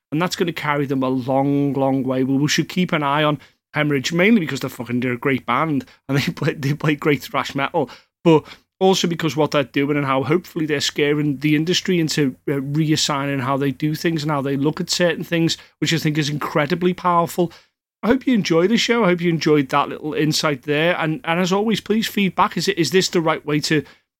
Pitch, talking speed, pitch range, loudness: 155 Hz, 230 wpm, 140-175 Hz, -19 LUFS